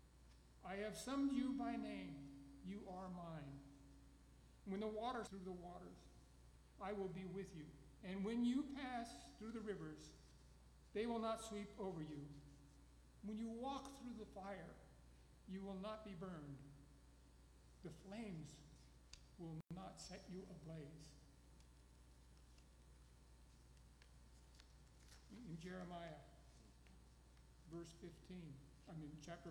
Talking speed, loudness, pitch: 120 wpm, -51 LUFS, 150 Hz